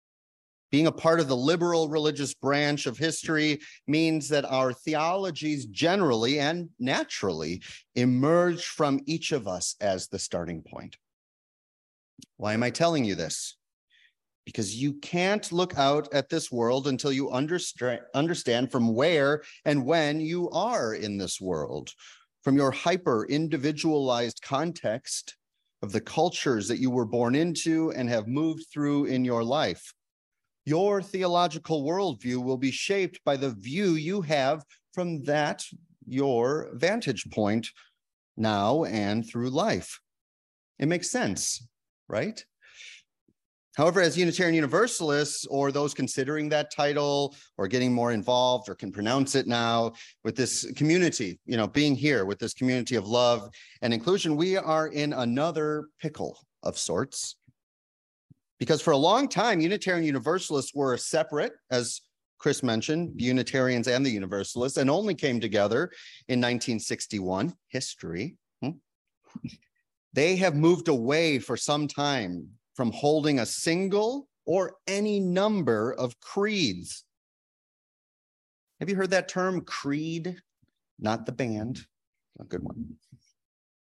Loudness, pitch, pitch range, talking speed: -27 LUFS, 145 Hz, 120-160 Hz, 135 wpm